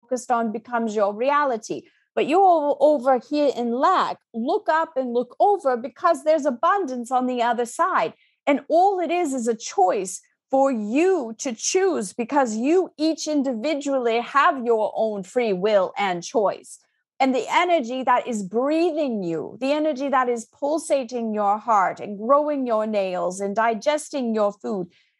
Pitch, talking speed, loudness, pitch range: 260 Hz, 160 wpm, -22 LUFS, 230-310 Hz